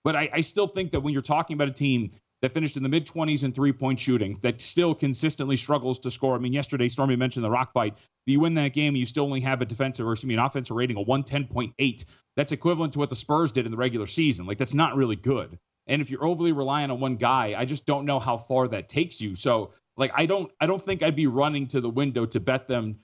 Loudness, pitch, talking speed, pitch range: -26 LUFS, 135 Hz, 265 wpm, 125-150 Hz